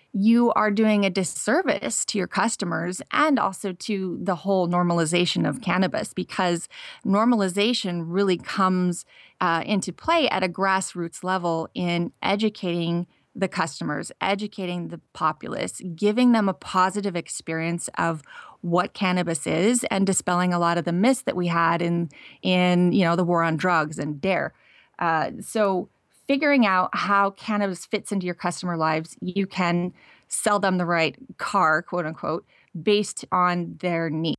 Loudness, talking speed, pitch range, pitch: -24 LUFS, 150 wpm, 170-205 Hz, 185 Hz